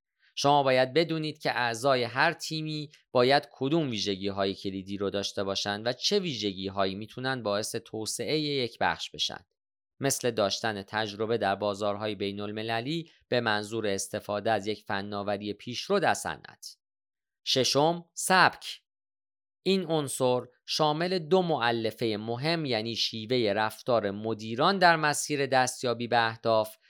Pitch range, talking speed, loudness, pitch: 105-150 Hz, 130 wpm, -28 LUFS, 120 Hz